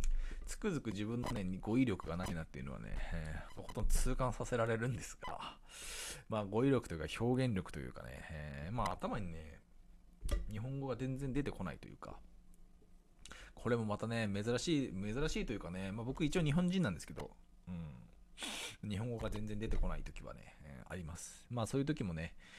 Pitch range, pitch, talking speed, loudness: 85-125 Hz, 105 Hz, 360 characters per minute, -40 LUFS